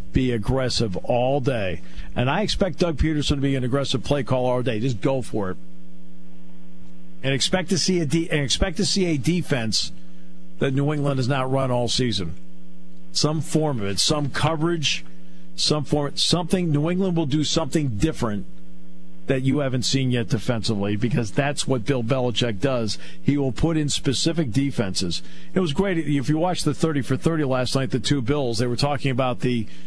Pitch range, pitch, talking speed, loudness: 100-150 Hz, 130 Hz, 190 wpm, -23 LUFS